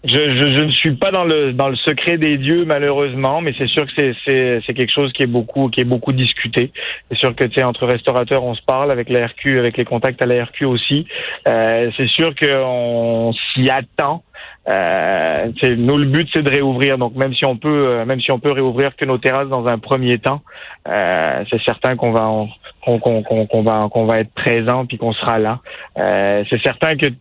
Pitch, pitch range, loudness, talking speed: 130 Hz, 120-140 Hz, -16 LUFS, 230 wpm